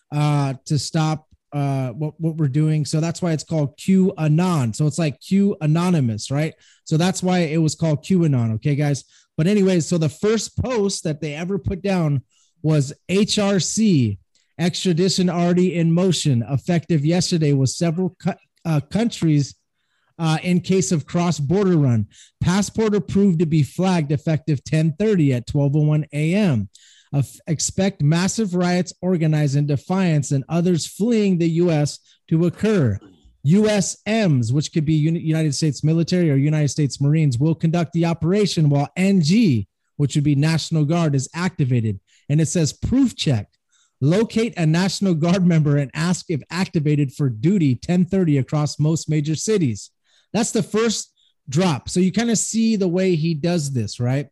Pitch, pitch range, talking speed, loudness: 160 Hz, 145-185 Hz, 160 wpm, -20 LUFS